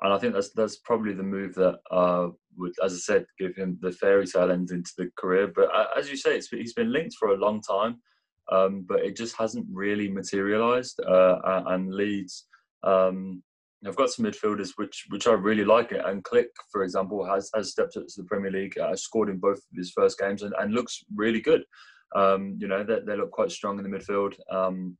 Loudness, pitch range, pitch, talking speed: -26 LUFS, 95-110 Hz, 100 Hz, 225 wpm